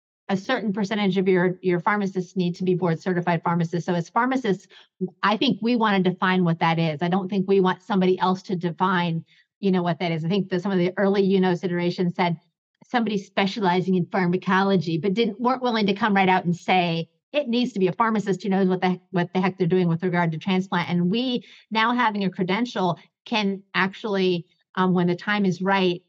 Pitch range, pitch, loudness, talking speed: 175-200 Hz, 185 Hz, -23 LUFS, 225 wpm